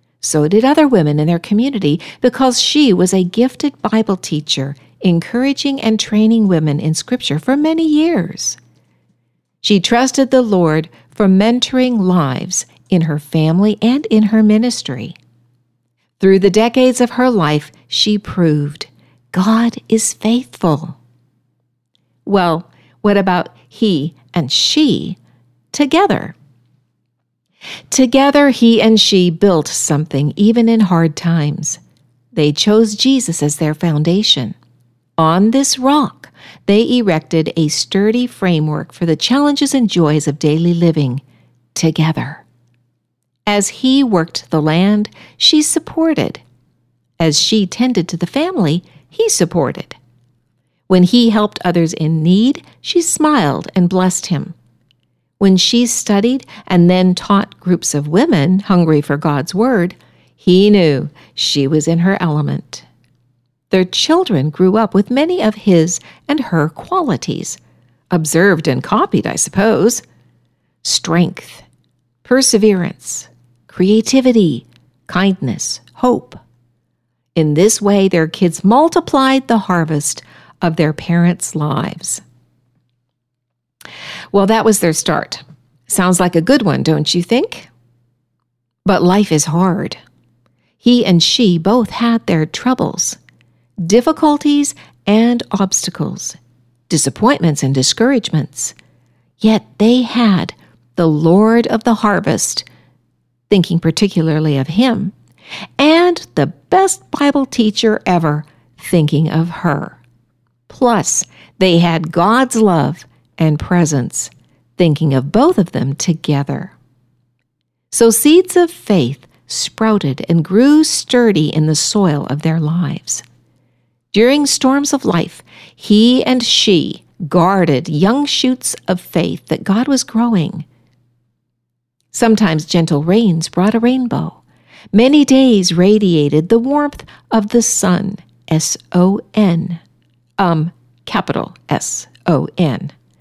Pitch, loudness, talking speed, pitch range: 175 Hz, -13 LUFS, 120 wpm, 145-225 Hz